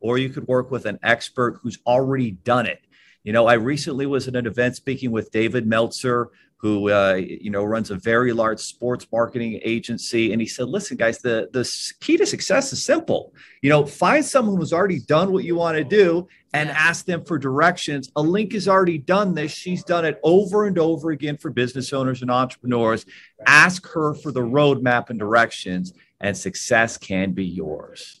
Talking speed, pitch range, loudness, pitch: 200 wpm, 115-165 Hz, -20 LUFS, 130 Hz